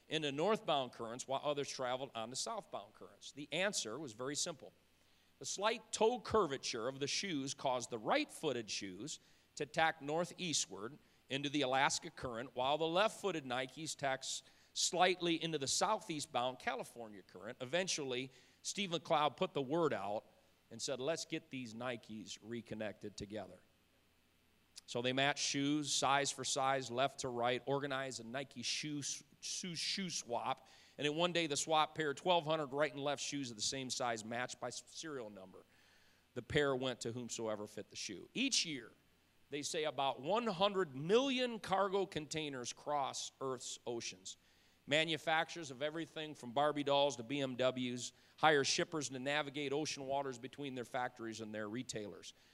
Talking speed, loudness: 155 wpm, -39 LUFS